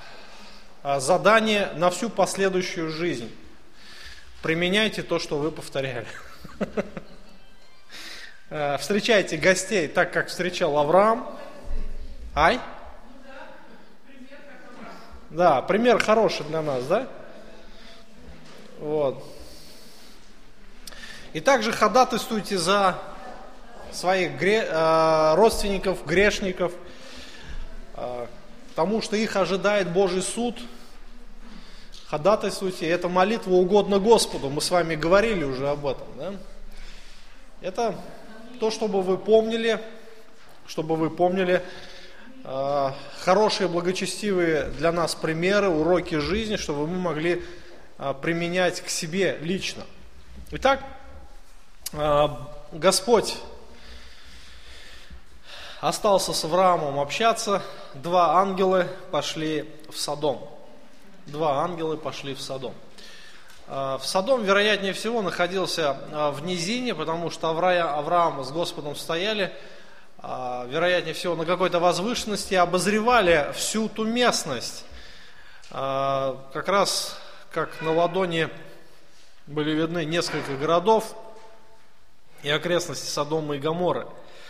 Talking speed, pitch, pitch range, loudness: 90 wpm, 180 Hz, 160-210 Hz, -24 LUFS